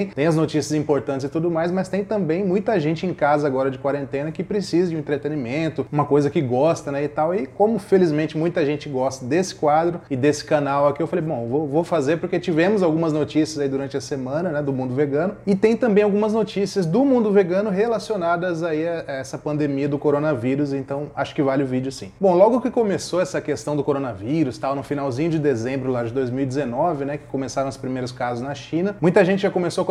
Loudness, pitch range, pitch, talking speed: -21 LUFS, 140-180 Hz, 155 Hz, 220 wpm